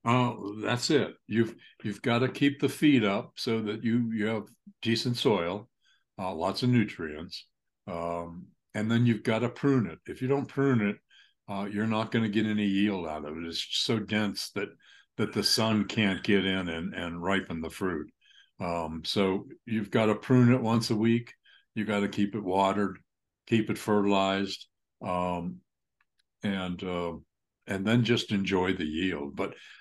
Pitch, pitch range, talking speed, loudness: 105 Hz, 95-115 Hz, 185 wpm, -29 LUFS